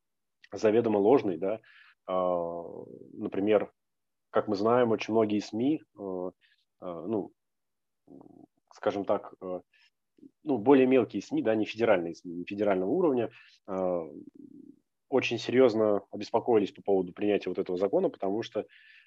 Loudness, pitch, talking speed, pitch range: -29 LUFS, 105 Hz, 110 wpm, 95-130 Hz